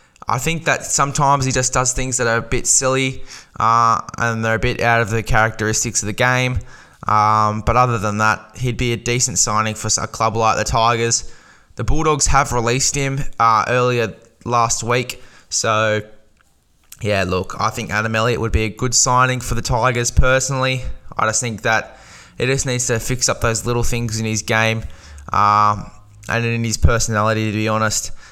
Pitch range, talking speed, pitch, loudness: 110-125 Hz, 190 wpm, 115 Hz, -17 LUFS